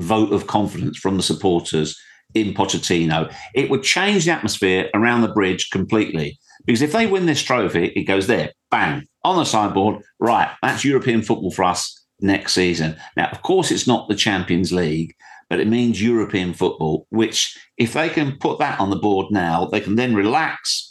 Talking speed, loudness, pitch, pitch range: 185 wpm, -19 LUFS, 100 Hz, 90-115 Hz